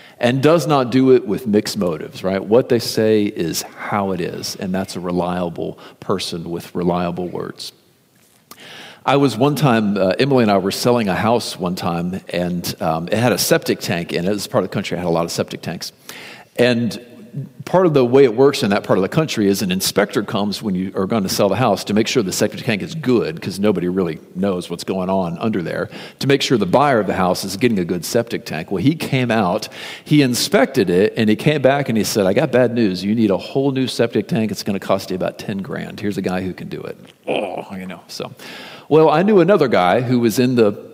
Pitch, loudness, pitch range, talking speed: 110 Hz, -18 LUFS, 95-135 Hz, 250 wpm